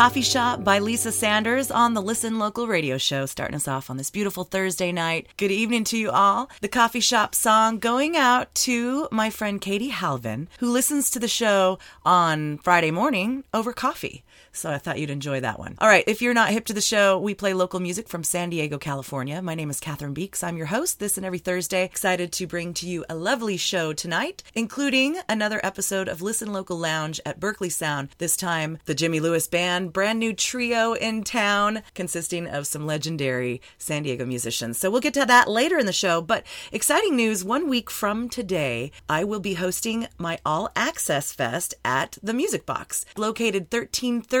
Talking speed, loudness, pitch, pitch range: 200 wpm, -23 LUFS, 195 Hz, 165-230 Hz